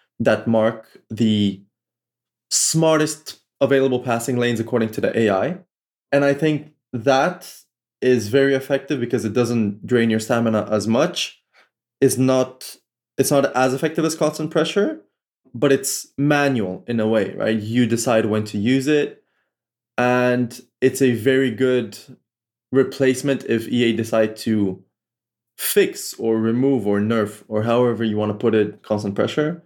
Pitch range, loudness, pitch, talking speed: 110-135 Hz, -20 LUFS, 120 Hz, 145 wpm